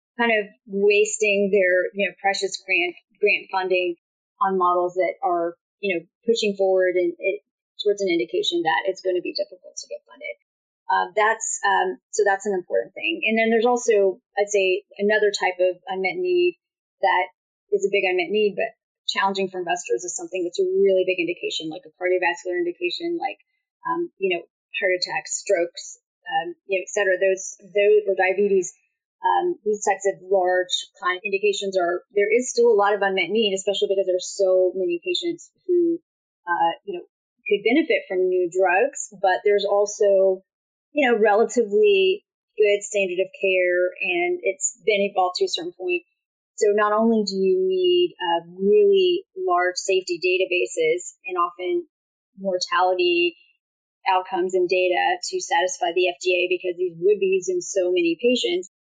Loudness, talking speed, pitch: -22 LUFS, 170 wpm, 205 Hz